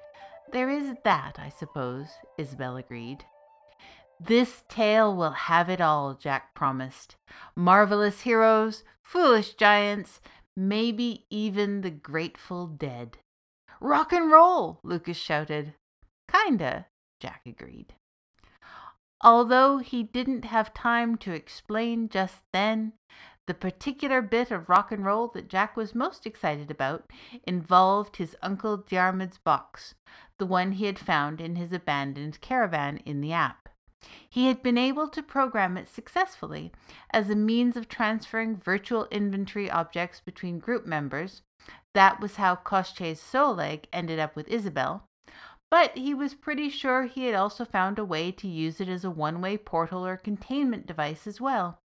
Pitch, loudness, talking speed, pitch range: 200 Hz, -26 LUFS, 140 wpm, 170-235 Hz